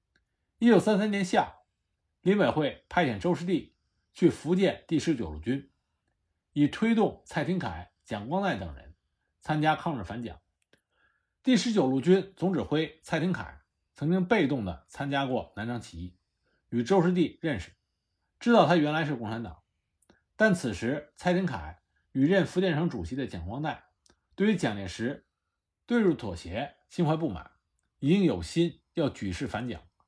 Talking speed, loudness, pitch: 230 characters per minute, -28 LUFS, 145 Hz